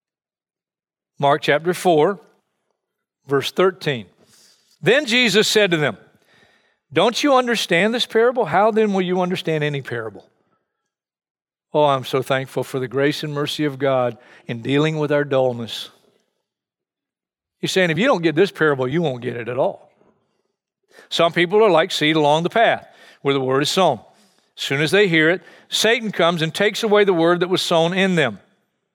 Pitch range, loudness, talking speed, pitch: 140-195 Hz, -18 LUFS, 170 wpm, 160 Hz